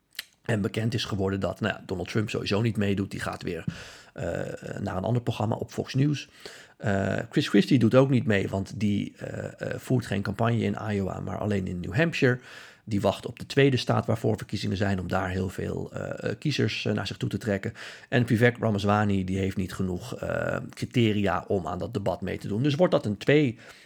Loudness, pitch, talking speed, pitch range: -27 LUFS, 105 Hz, 215 wpm, 100-120 Hz